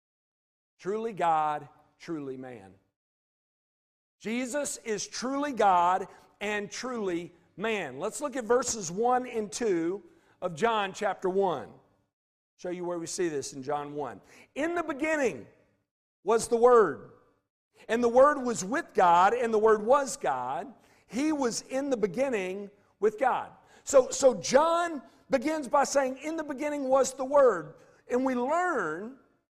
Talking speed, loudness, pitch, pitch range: 145 wpm, -28 LUFS, 230 Hz, 180-280 Hz